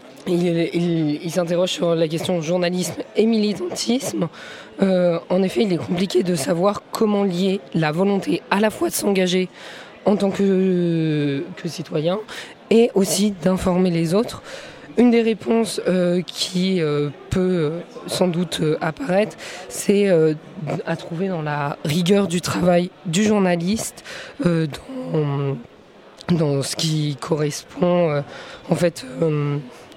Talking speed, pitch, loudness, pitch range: 135 wpm, 180 Hz, -20 LUFS, 160-195 Hz